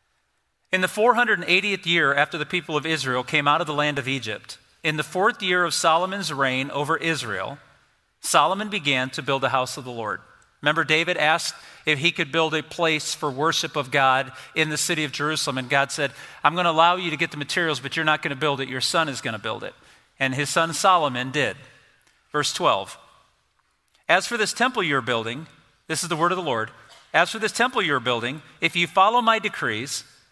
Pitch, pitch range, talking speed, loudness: 155 Hz, 140-170 Hz, 215 wpm, -22 LUFS